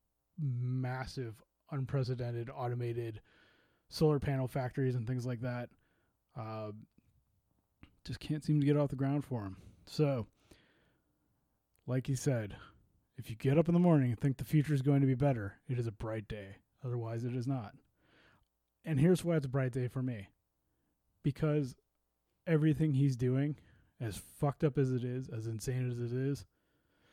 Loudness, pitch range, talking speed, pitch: -35 LUFS, 115-140 Hz, 165 wpm, 130 Hz